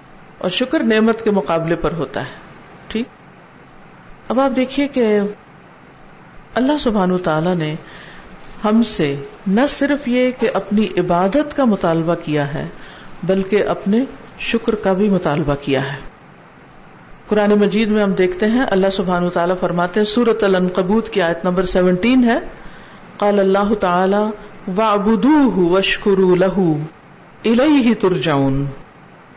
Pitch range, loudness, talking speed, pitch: 180-225 Hz, -17 LUFS, 130 wpm, 195 Hz